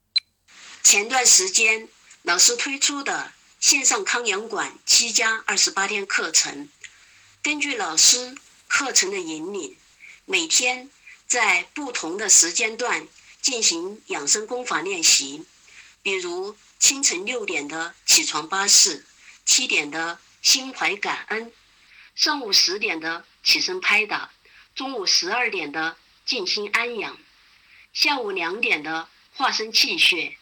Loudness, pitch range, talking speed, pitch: -19 LUFS, 220-350 Hz, 185 characters per minute, 265 Hz